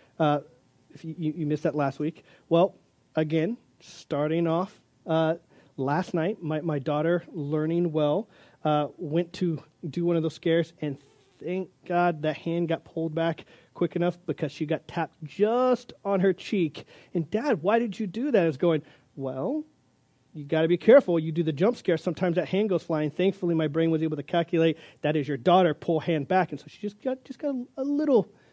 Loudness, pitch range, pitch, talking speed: -27 LUFS, 155-185 Hz, 165 Hz, 200 wpm